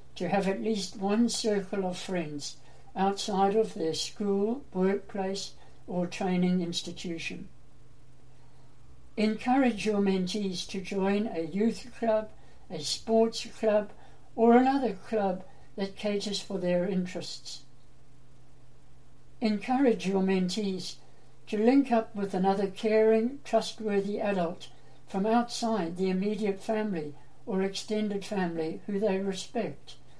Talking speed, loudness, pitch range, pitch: 115 wpm, -29 LUFS, 180-220 Hz, 195 Hz